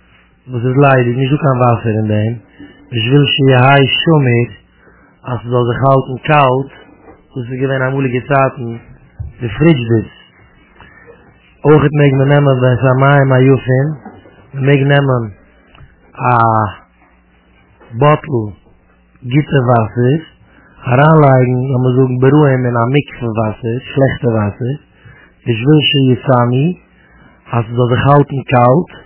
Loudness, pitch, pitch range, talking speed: -12 LUFS, 130 Hz, 120-140 Hz, 145 wpm